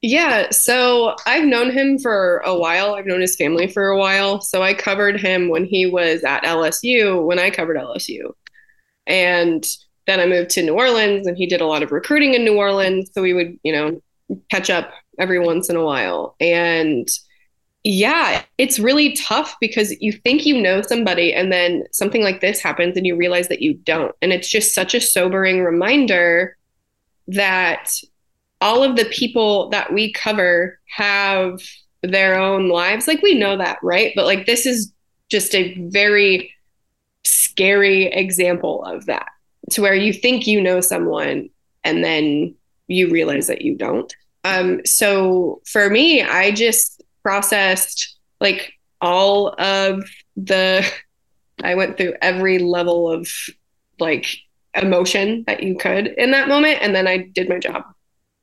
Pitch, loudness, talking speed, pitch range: 190 Hz, -16 LUFS, 165 wpm, 180-215 Hz